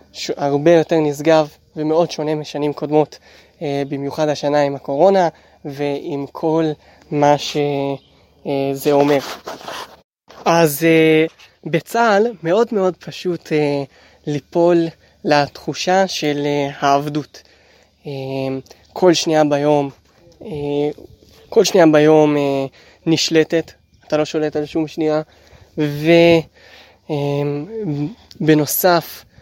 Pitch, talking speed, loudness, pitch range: 150 Hz, 80 wpm, -17 LUFS, 145-165 Hz